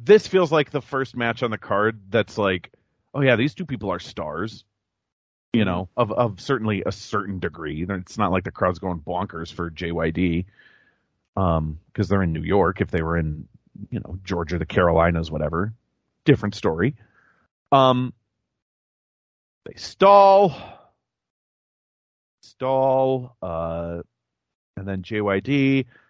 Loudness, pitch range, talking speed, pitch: -22 LUFS, 90-125 Hz, 140 wpm, 100 Hz